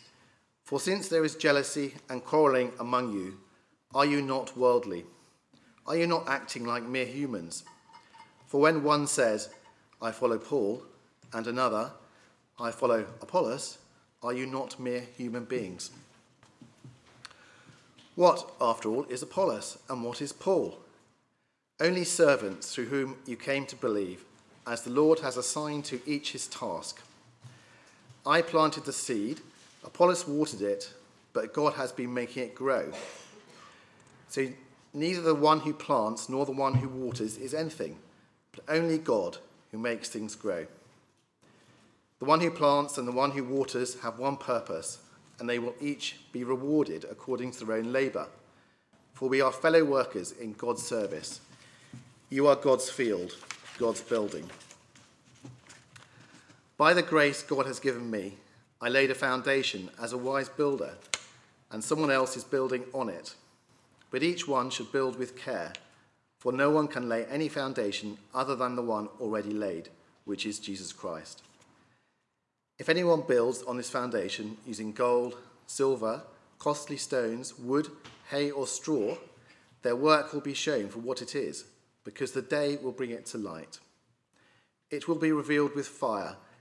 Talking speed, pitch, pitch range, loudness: 150 wpm, 130 Hz, 120-145 Hz, -30 LUFS